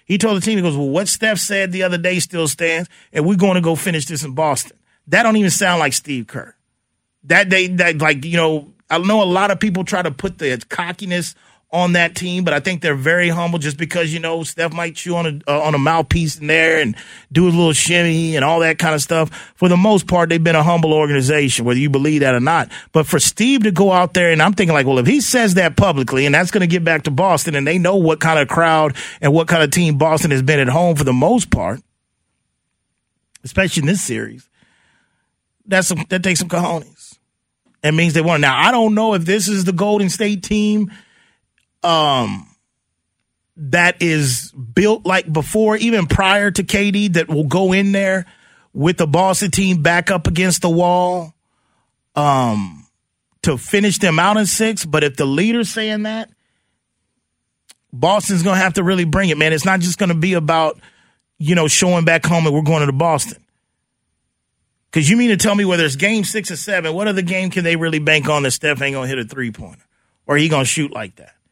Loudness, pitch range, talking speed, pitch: -15 LUFS, 155-190 Hz, 220 wpm, 170 Hz